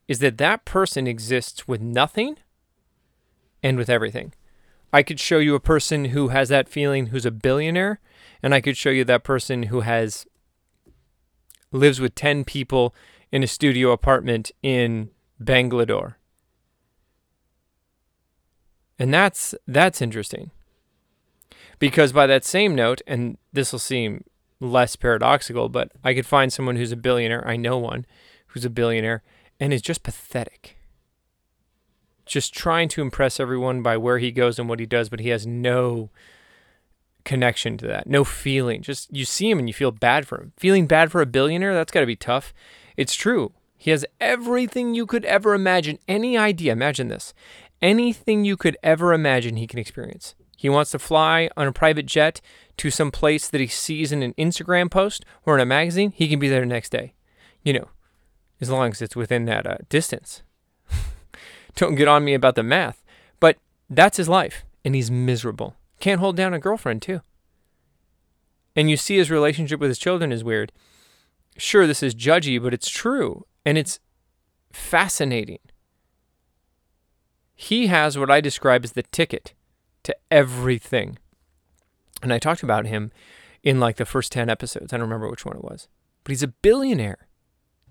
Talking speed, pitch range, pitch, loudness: 170 wpm, 115-155 Hz, 130 Hz, -21 LUFS